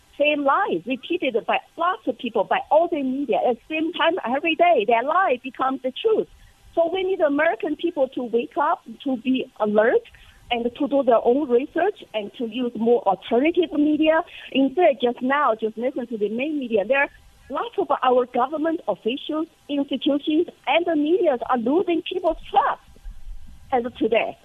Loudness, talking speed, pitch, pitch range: -22 LUFS, 175 wpm, 285 Hz, 250-330 Hz